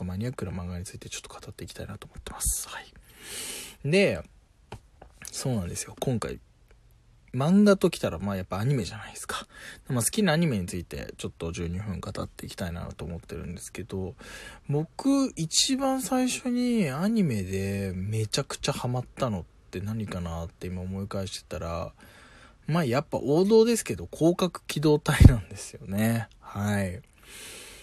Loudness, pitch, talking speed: -28 LUFS, 110 Hz, 340 characters per minute